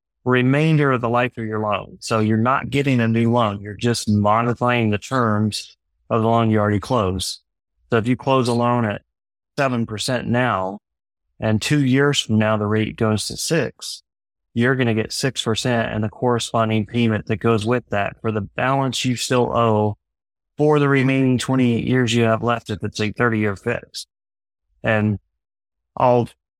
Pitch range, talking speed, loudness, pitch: 105-125 Hz, 180 wpm, -20 LUFS, 115 Hz